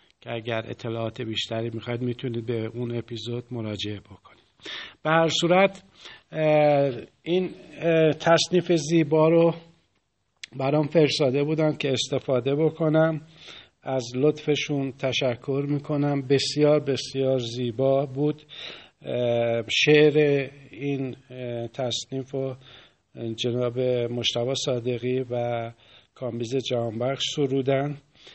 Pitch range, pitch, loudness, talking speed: 120-150 Hz, 135 Hz, -24 LUFS, 90 wpm